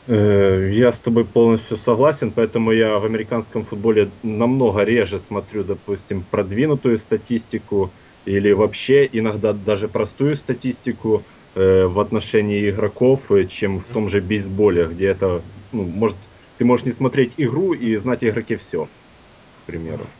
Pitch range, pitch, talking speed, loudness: 100-120 Hz, 110 Hz, 135 wpm, -19 LUFS